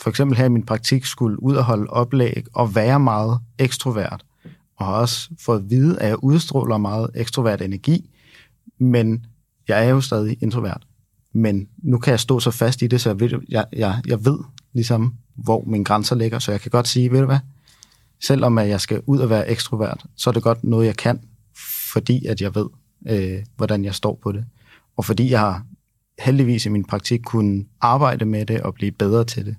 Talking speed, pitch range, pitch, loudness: 205 wpm, 110-130 Hz, 115 Hz, -20 LUFS